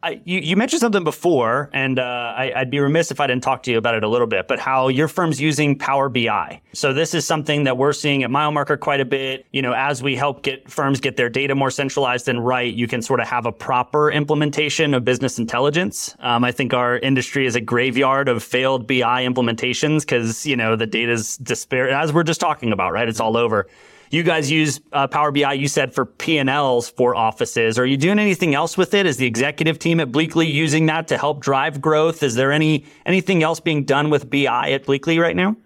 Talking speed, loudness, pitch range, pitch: 235 wpm, -19 LUFS, 125-155 Hz, 140 Hz